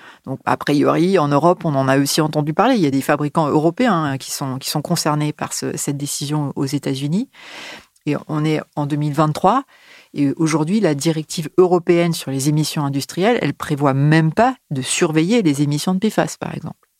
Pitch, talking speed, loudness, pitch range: 155 Hz, 190 wpm, -18 LUFS, 145-175 Hz